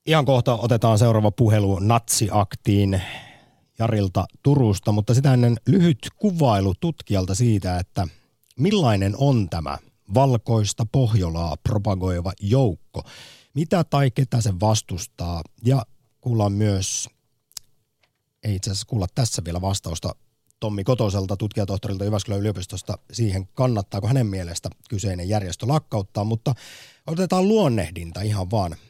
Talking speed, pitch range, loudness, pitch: 115 wpm, 100-130 Hz, -22 LUFS, 110 Hz